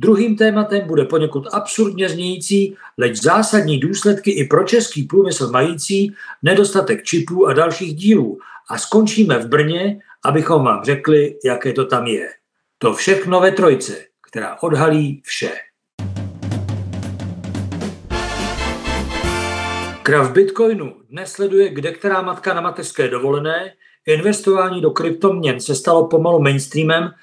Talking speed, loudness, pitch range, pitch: 120 wpm, -17 LUFS, 140-195 Hz, 165 Hz